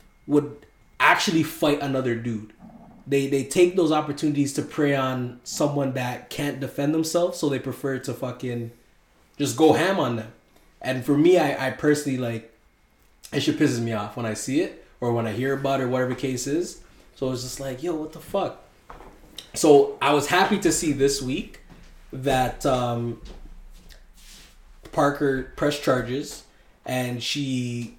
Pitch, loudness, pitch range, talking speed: 135 Hz, -24 LUFS, 125-150 Hz, 165 wpm